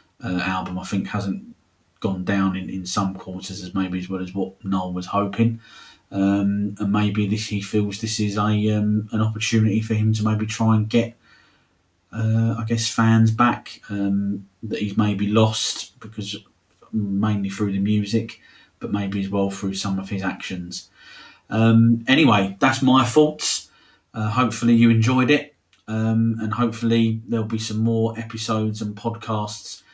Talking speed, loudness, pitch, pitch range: 165 wpm, -22 LUFS, 105 Hz, 100-115 Hz